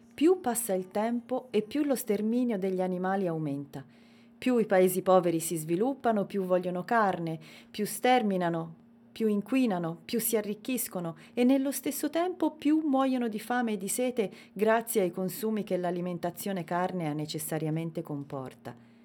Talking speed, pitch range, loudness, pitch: 145 wpm, 175-240 Hz, -30 LUFS, 205 Hz